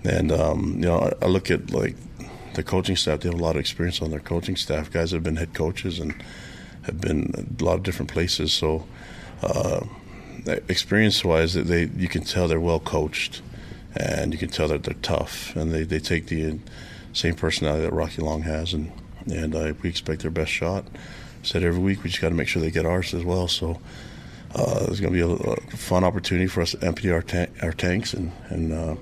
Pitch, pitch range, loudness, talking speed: 85 Hz, 80-90 Hz, -25 LUFS, 225 wpm